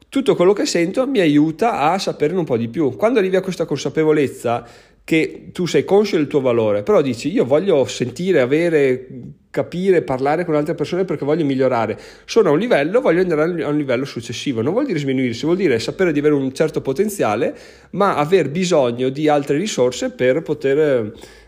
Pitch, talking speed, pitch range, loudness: 155 Hz, 190 wpm, 135-185 Hz, -18 LUFS